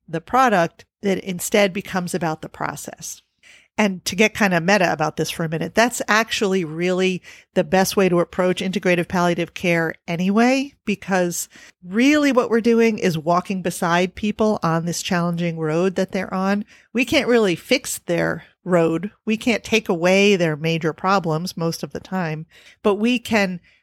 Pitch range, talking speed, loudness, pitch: 170-215 Hz, 170 wpm, -20 LUFS, 185 Hz